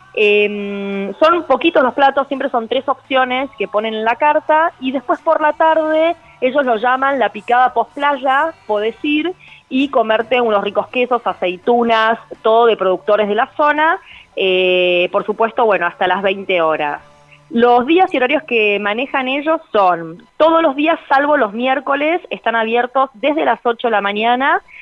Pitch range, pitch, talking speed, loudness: 210-290 Hz, 245 Hz, 170 wpm, -15 LUFS